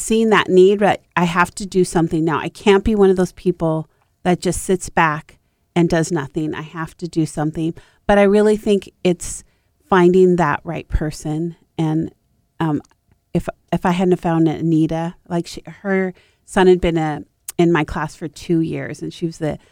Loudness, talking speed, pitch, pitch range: -18 LUFS, 195 wpm, 170 Hz, 160-185 Hz